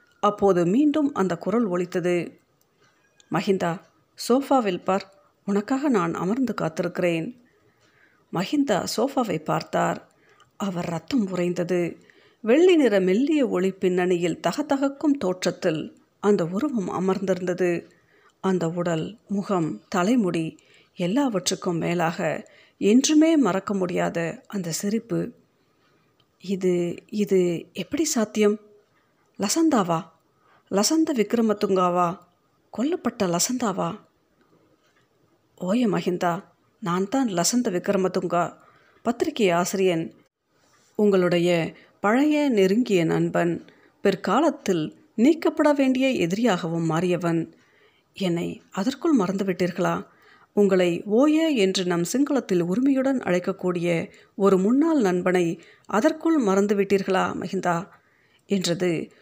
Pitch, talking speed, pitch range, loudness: 190 Hz, 85 wpm, 175-240 Hz, -23 LUFS